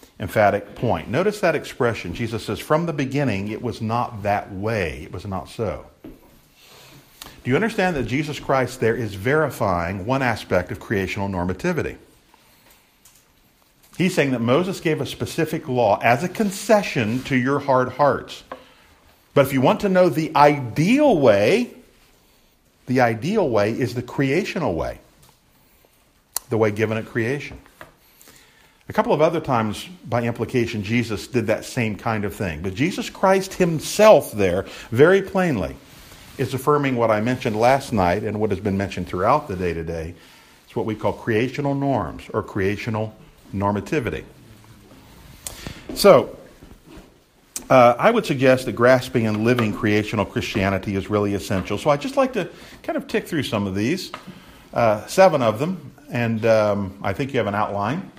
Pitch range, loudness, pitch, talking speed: 105-150 Hz, -21 LUFS, 120 Hz, 160 wpm